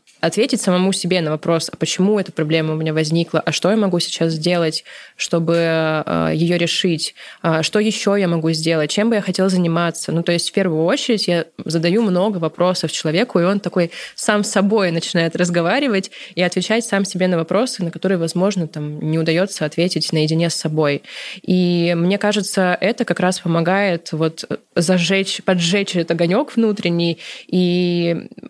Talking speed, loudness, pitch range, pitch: 170 wpm, -18 LUFS, 165-195 Hz, 175 Hz